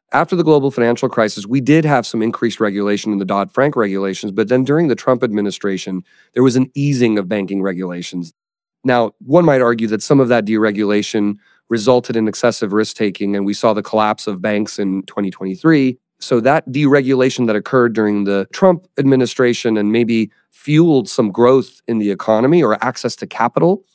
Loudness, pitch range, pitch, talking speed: -15 LUFS, 105-130 Hz, 115 Hz, 185 wpm